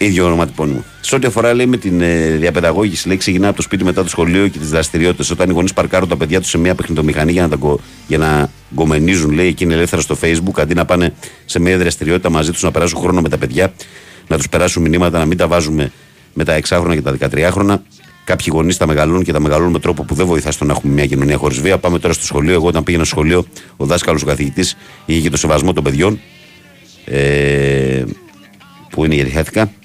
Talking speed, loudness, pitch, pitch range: 220 wpm, -14 LUFS, 85 Hz, 75-90 Hz